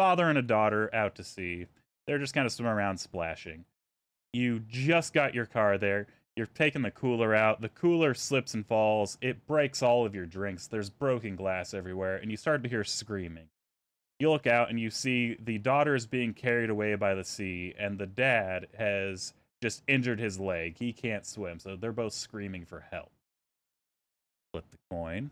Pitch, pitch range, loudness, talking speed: 110 Hz, 95-125 Hz, -30 LUFS, 190 wpm